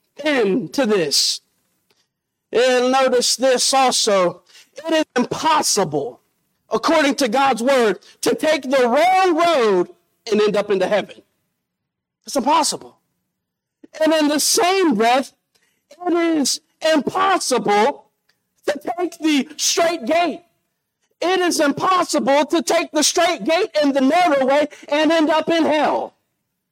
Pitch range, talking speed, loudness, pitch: 255-330 Hz, 125 wpm, -17 LUFS, 300 Hz